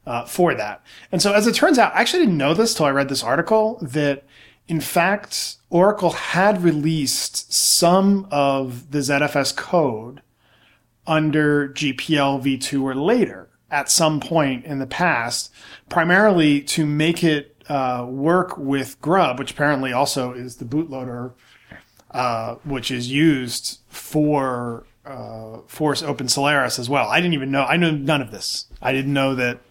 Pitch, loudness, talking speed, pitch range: 140 Hz, -19 LUFS, 160 wpm, 130-160 Hz